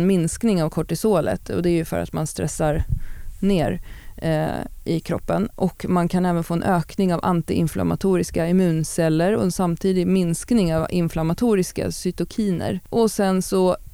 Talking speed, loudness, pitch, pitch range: 150 wpm, -22 LUFS, 175 Hz, 160-190 Hz